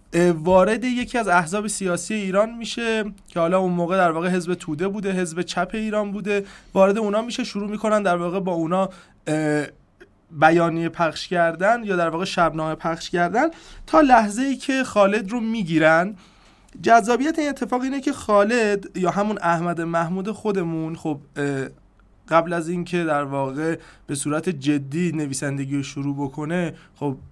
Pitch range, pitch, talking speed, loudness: 165-210 Hz, 180 Hz, 155 wpm, -22 LUFS